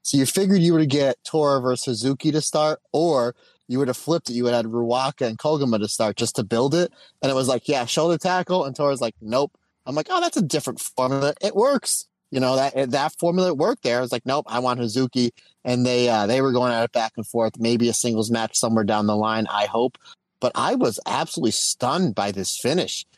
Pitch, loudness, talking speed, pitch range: 130 Hz, -22 LUFS, 245 wpm, 115-150 Hz